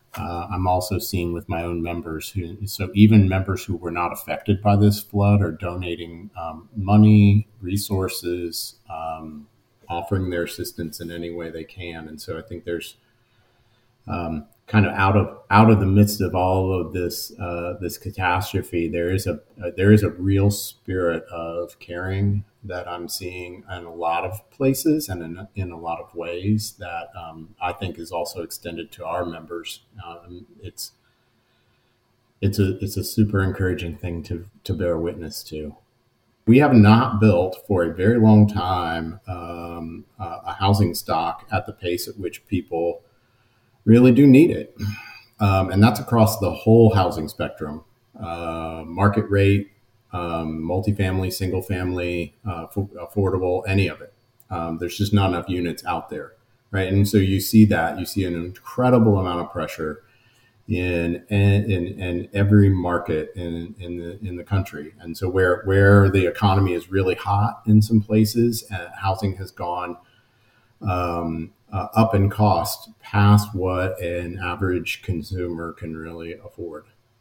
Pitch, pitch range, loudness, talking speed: 95 Hz, 85-105 Hz, -21 LUFS, 165 wpm